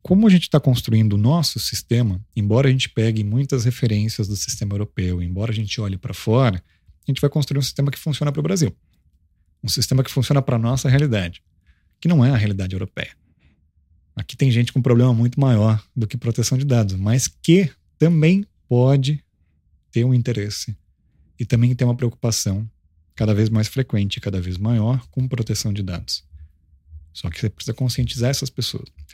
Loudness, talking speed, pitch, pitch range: -20 LUFS, 185 wpm, 115 Hz, 95-130 Hz